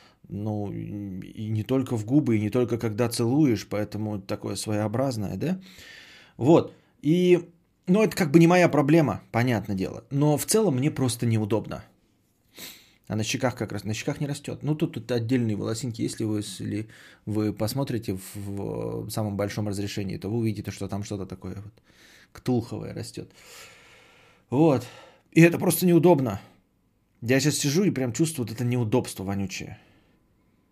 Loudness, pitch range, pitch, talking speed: -25 LUFS, 105-145 Hz, 115 Hz, 160 wpm